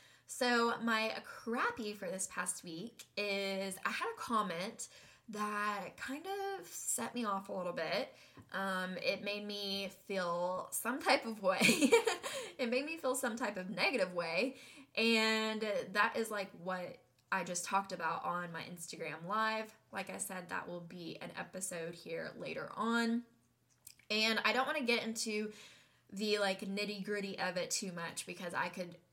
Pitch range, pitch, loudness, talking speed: 185-230 Hz, 205 Hz, -37 LUFS, 165 wpm